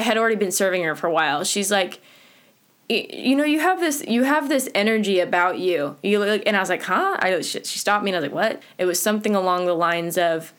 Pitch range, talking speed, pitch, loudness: 180-225 Hz, 255 wpm, 200 Hz, -21 LUFS